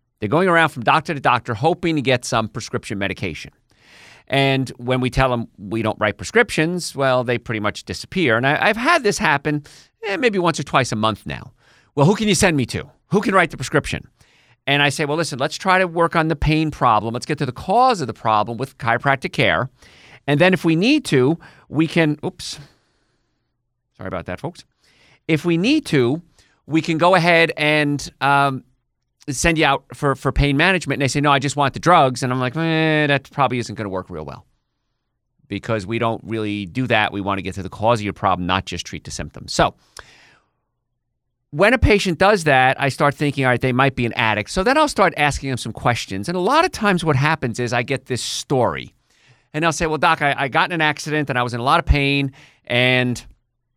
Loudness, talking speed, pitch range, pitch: -18 LUFS, 230 wpm, 120-160 Hz, 140 Hz